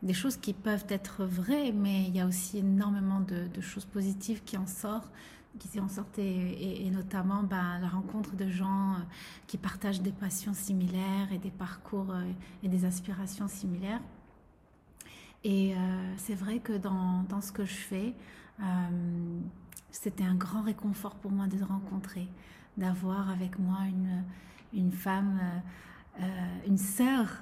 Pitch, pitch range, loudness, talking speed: 195 Hz, 185-200 Hz, -34 LUFS, 160 wpm